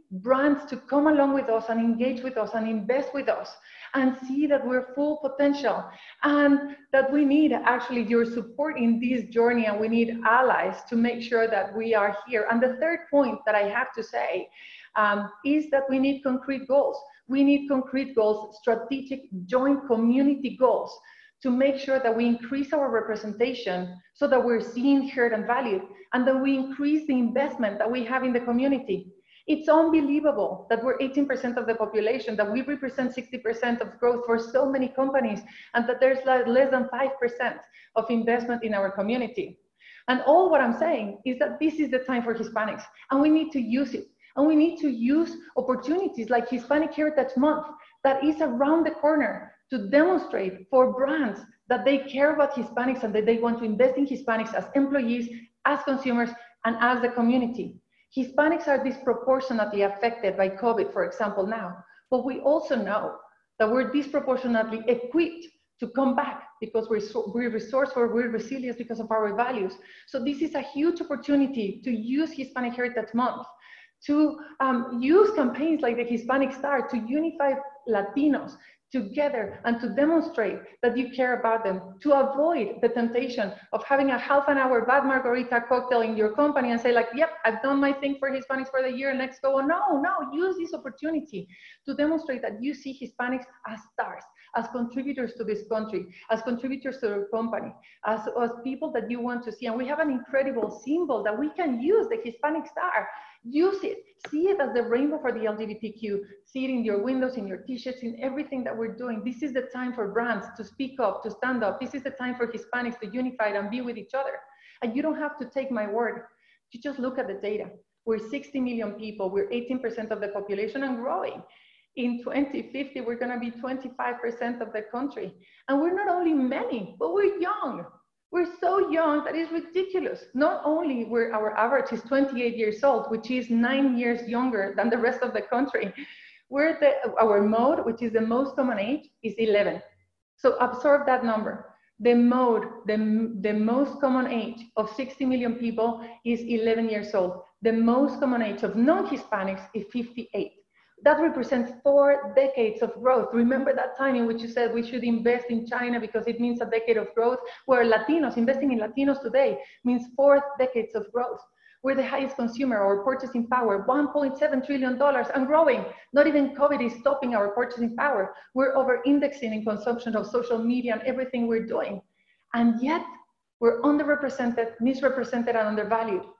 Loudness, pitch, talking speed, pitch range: -26 LUFS, 250 Hz, 185 wpm, 230-280 Hz